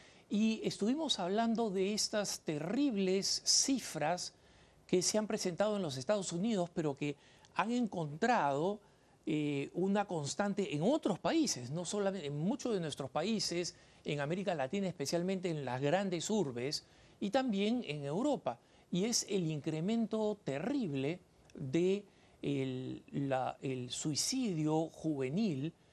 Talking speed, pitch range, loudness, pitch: 125 wpm, 150-210 Hz, -36 LUFS, 185 Hz